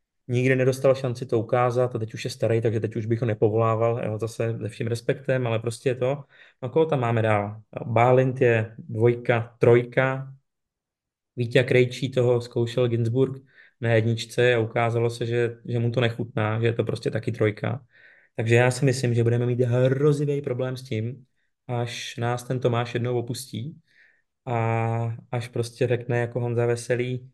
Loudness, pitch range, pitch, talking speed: -24 LUFS, 115-130 Hz, 120 Hz, 175 wpm